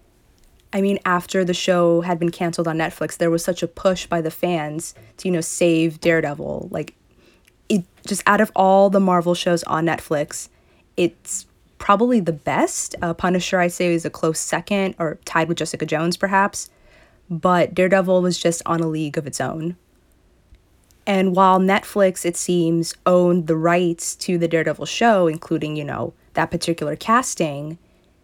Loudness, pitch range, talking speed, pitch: -20 LUFS, 160-185 Hz, 170 wpm, 170 Hz